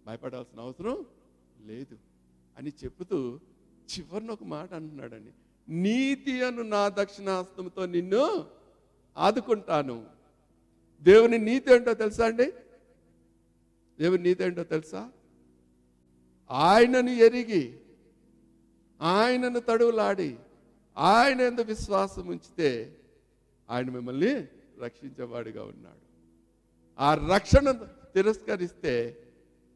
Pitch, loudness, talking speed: 150 Hz, -26 LUFS, 75 wpm